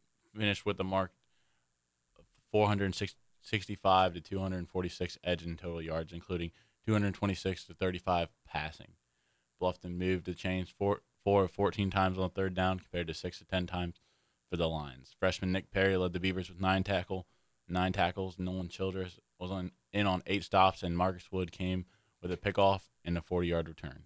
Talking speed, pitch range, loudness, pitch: 175 wpm, 85-95 Hz, -34 LUFS, 95 Hz